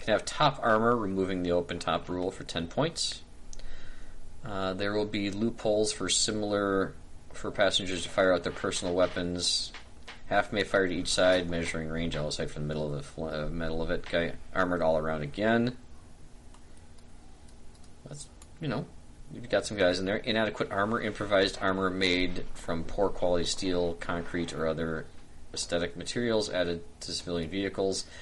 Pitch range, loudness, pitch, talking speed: 80-95 Hz, -30 LUFS, 85 Hz, 160 wpm